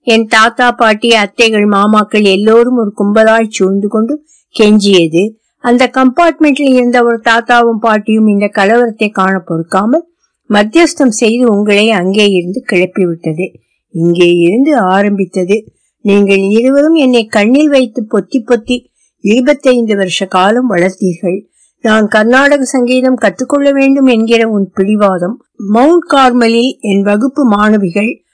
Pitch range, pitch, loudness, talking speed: 200-255 Hz, 225 Hz, -9 LUFS, 80 wpm